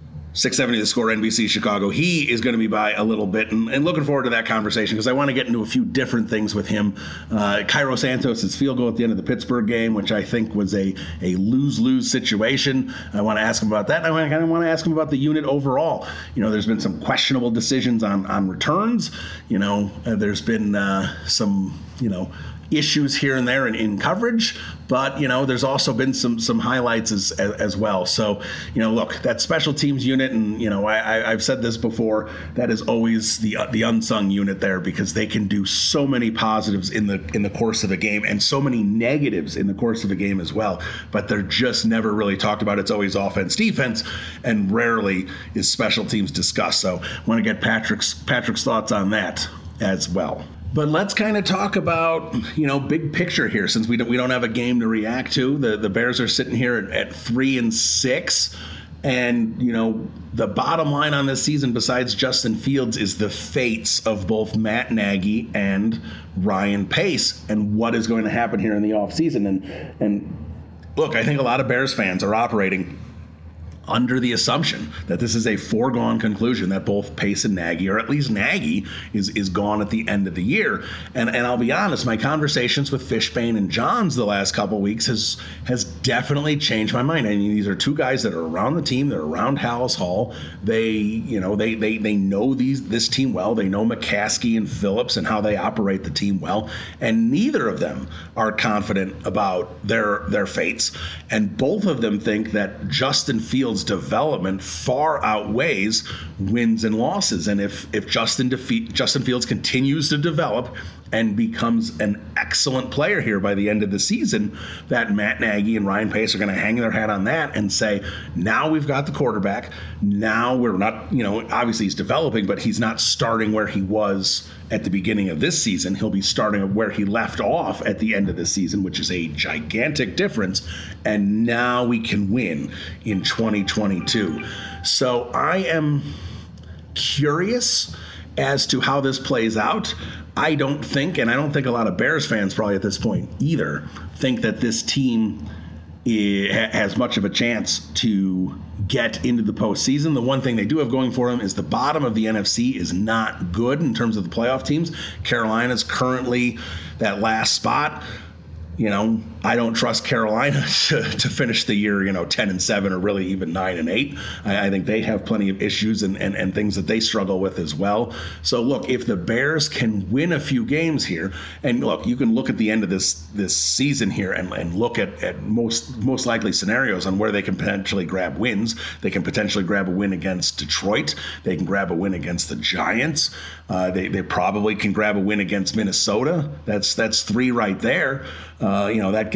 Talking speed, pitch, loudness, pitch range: 210 wpm, 110 Hz, -21 LUFS, 100-125 Hz